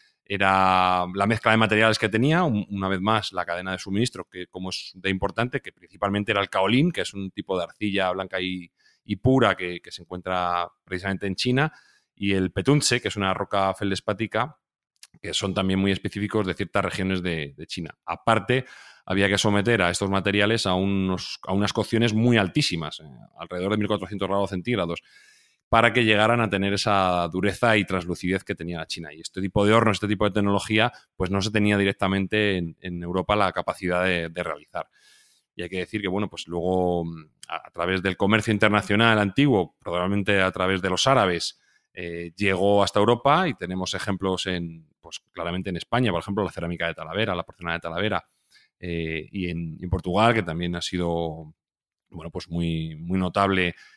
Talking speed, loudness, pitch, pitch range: 190 wpm, -24 LUFS, 95 Hz, 90-105 Hz